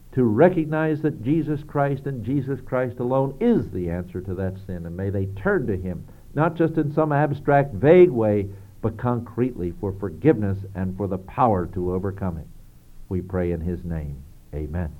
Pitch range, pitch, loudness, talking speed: 90-140 Hz, 105 Hz, -23 LUFS, 180 wpm